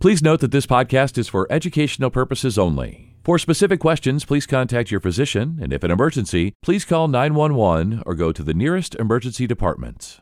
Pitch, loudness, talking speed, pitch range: 130 Hz, -19 LUFS, 180 wpm, 100-150 Hz